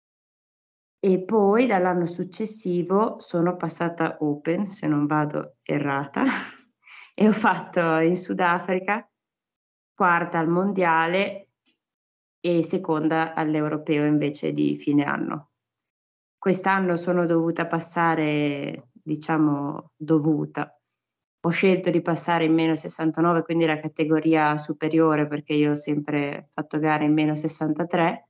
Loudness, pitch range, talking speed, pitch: -23 LUFS, 150-180 Hz, 110 wpm, 165 Hz